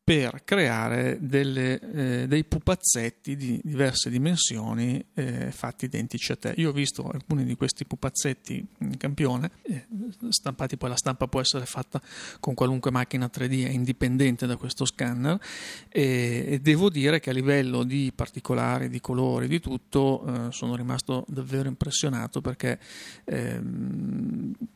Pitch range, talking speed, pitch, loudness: 125-145 Hz, 140 wpm, 135 Hz, -27 LUFS